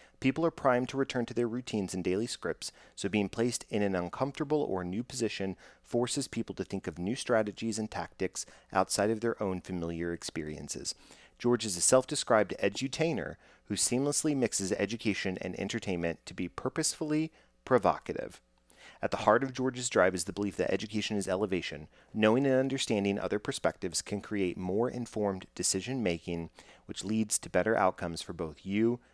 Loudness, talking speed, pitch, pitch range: -32 LUFS, 170 wpm, 105 Hz, 95-125 Hz